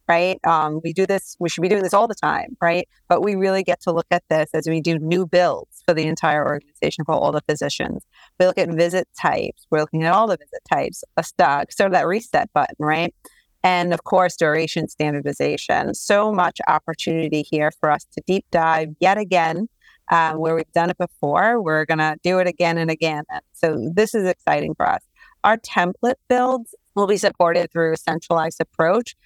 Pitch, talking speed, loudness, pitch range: 170 Hz, 210 wpm, -20 LUFS, 160-185 Hz